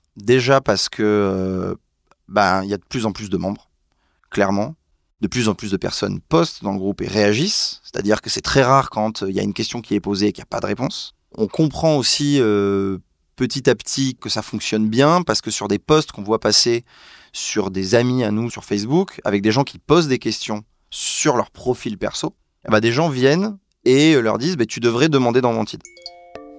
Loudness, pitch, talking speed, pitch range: -19 LUFS, 110 Hz, 230 wpm, 100-135 Hz